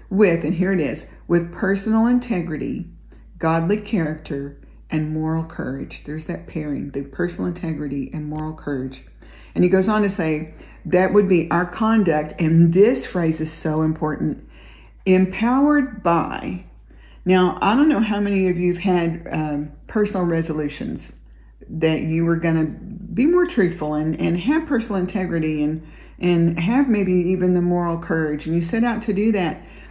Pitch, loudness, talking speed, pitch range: 170 Hz, -21 LUFS, 165 wpm, 155-195 Hz